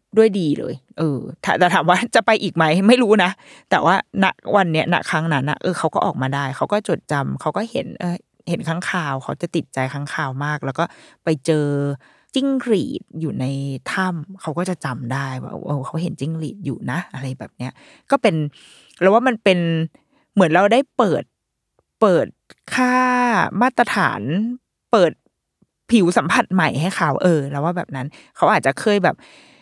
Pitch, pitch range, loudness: 170 Hz, 145-205 Hz, -19 LUFS